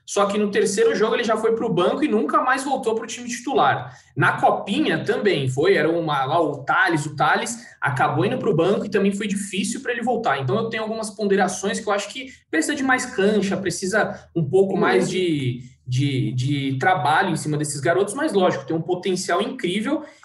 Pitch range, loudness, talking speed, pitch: 170-230 Hz, -21 LUFS, 215 wpm, 200 Hz